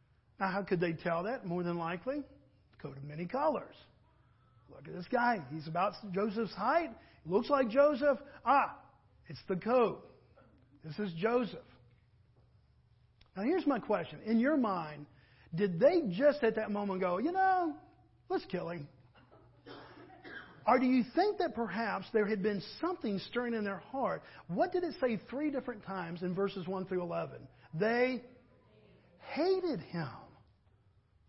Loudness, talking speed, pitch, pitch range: -34 LUFS, 150 wpm, 200 Hz, 165-255 Hz